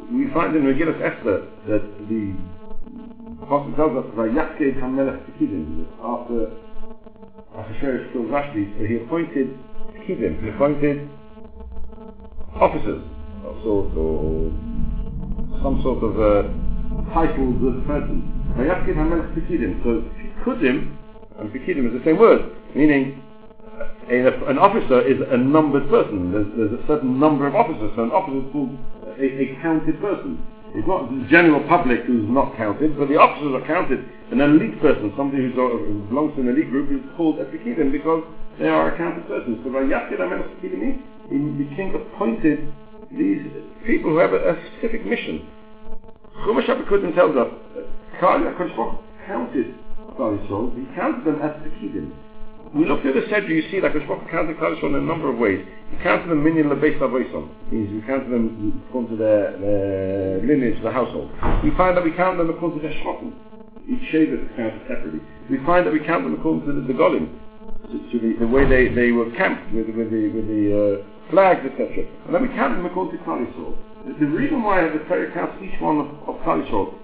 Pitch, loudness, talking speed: 145 Hz, -21 LUFS, 160 wpm